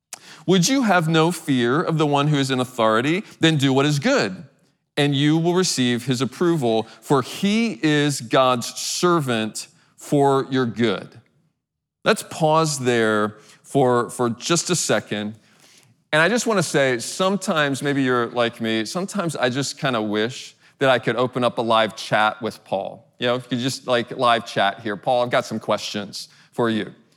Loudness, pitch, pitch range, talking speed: -21 LUFS, 135 Hz, 120-160 Hz, 185 wpm